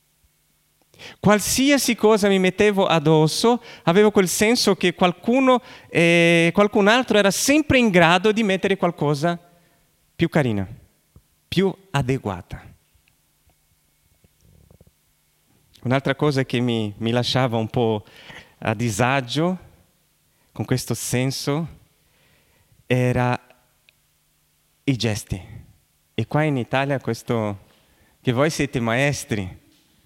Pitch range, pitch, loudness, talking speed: 110-180 Hz, 135 Hz, -20 LUFS, 100 wpm